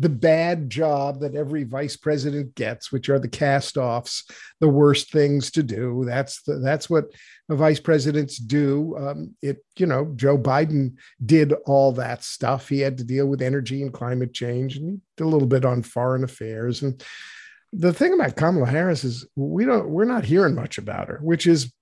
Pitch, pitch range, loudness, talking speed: 140 Hz, 130-155 Hz, -22 LUFS, 195 wpm